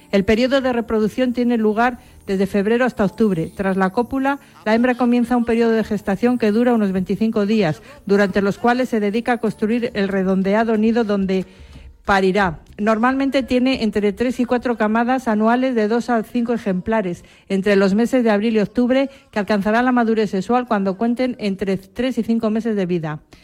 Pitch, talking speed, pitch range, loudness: 220 Hz, 180 wpm, 200-245 Hz, -18 LUFS